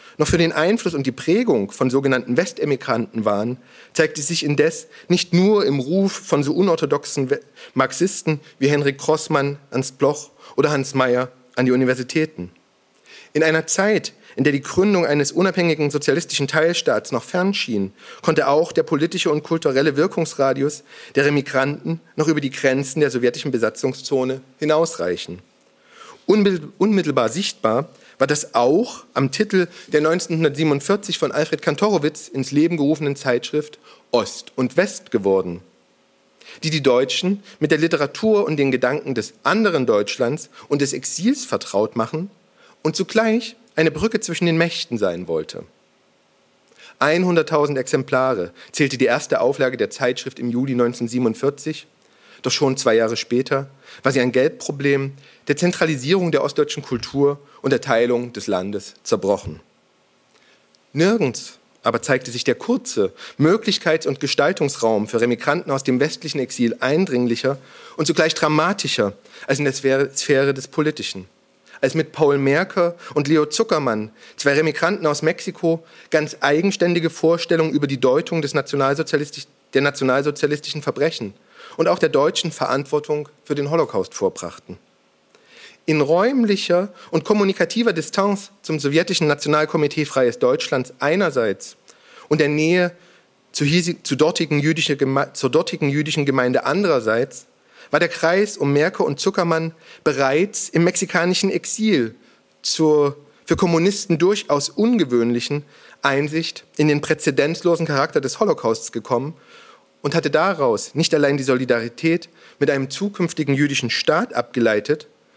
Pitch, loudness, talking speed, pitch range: 150 Hz, -20 LUFS, 135 wpm, 135-170 Hz